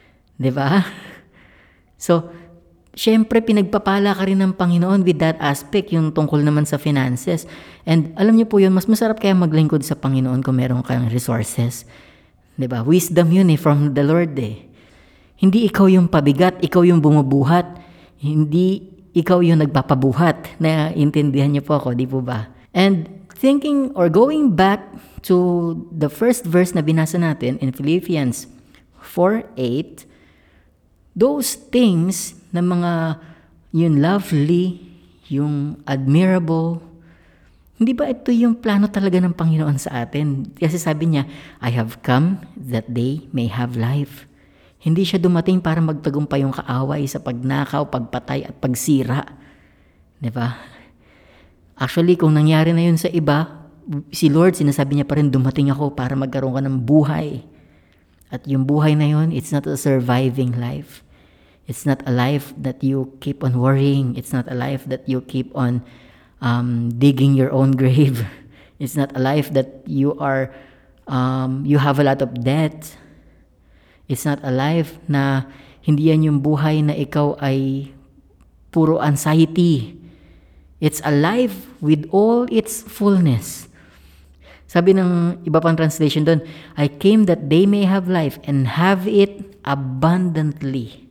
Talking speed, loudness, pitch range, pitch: 145 wpm, -18 LUFS, 130-175 Hz, 150 Hz